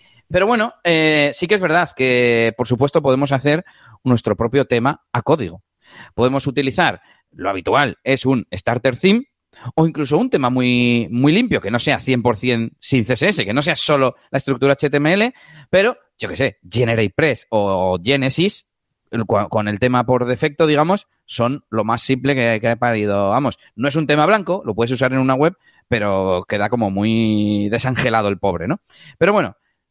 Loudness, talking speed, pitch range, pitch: -17 LUFS, 180 wpm, 115-150 Hz, 130 Hz